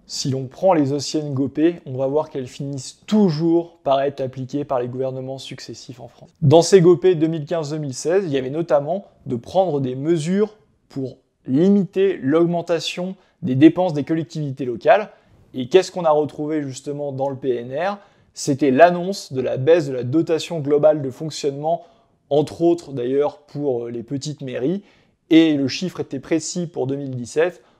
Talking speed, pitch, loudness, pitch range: 160 wpm, 150 Hz, -20 LUFS, 135-170 Hz